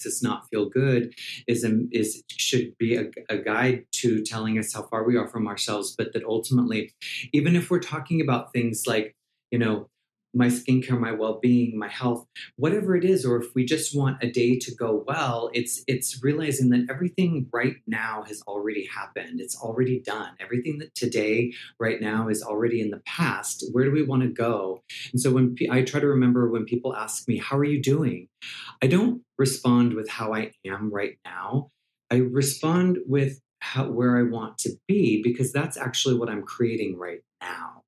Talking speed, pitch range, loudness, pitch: 195 wpm, 115-135 Hz, -25 LUFS, 125 Hz